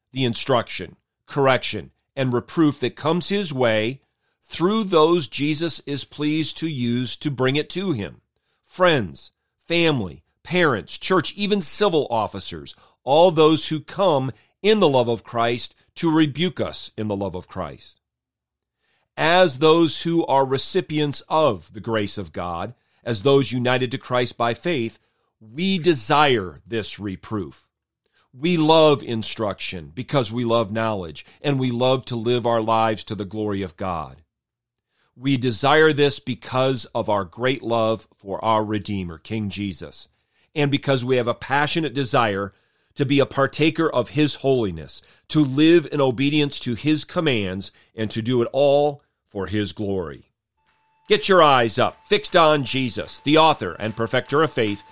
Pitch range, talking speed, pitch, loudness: 110-155 Hz, 155 wpm, 130 Hz, -21 LUFS